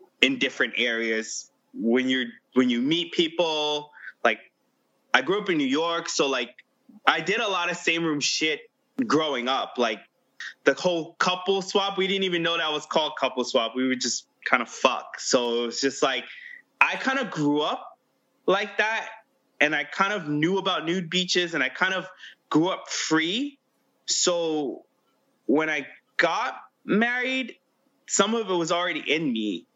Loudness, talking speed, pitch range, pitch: -25 LUFS, 175 wpm, 150-230 Hz, 180 Hz